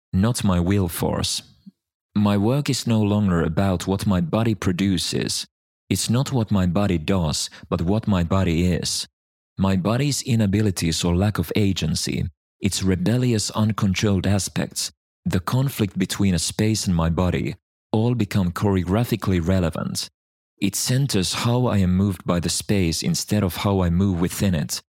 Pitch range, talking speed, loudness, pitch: 90-110 Hz, 155 wpm, -22 LUFS, 100 Hz